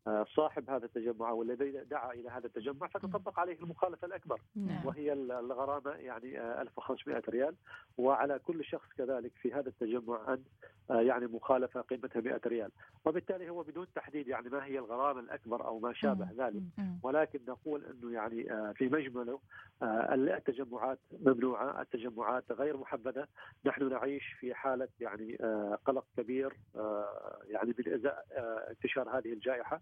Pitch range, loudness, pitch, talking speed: 120-145 Hz, -37 LUFS, 130 Hz, 135 wpm